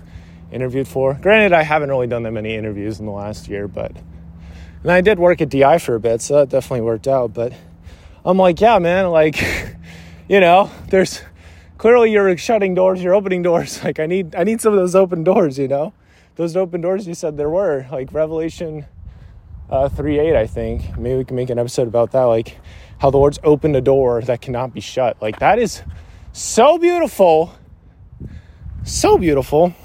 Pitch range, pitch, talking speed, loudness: 105-175 Hz, 135 Hz, 195 wpm, -16 LUFS